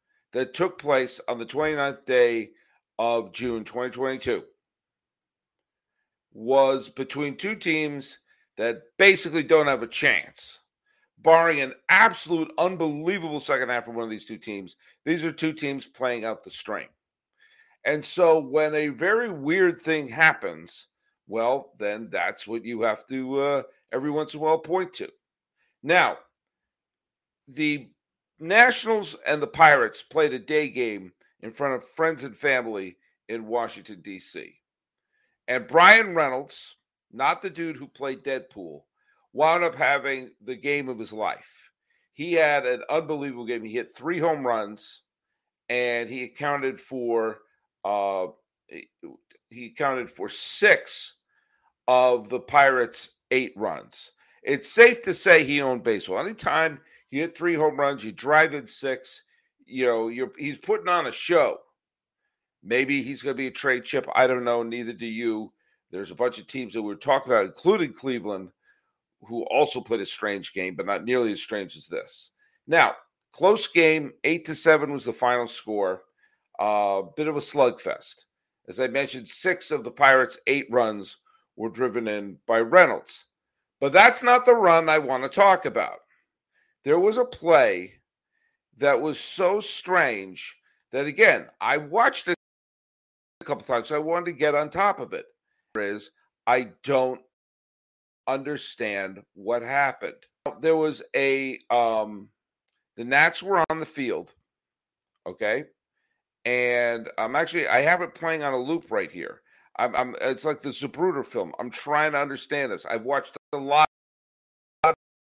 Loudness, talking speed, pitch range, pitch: -23 LUFS, 155 wpm, 120-170 Hz, 140 Hz